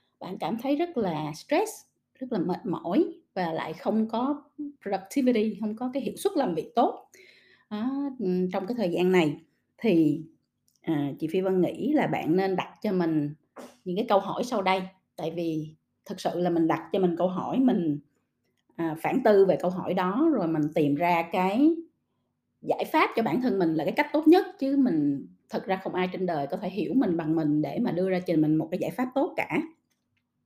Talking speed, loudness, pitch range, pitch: 215 wpm, -27 LUFS, 170-265 Hz, 190 Hz